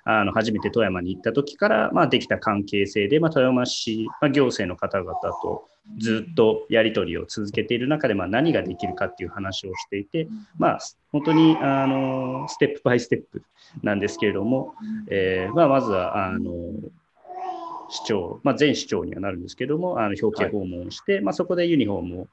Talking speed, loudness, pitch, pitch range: 365 characters per minute, -23 LUFS, 125 Hz, 105-160 Hz